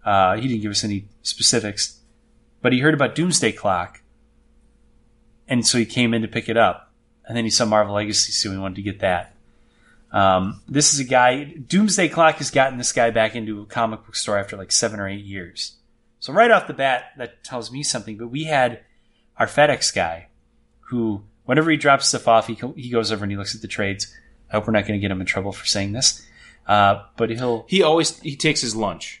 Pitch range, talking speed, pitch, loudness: 105-125 Hz, 225 wpm, 115 Hz, -20 LUFS